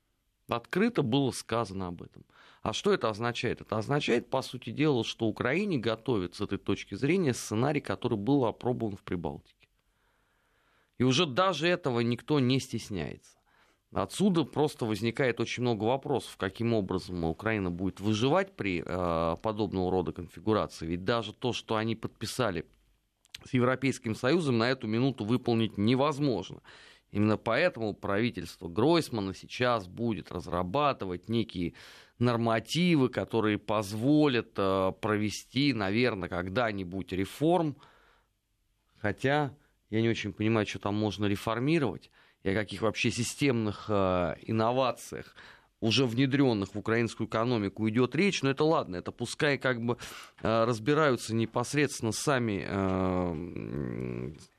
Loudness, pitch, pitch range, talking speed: -30 LUFS, 115 Hz, 100-125 Hz, 120 wpm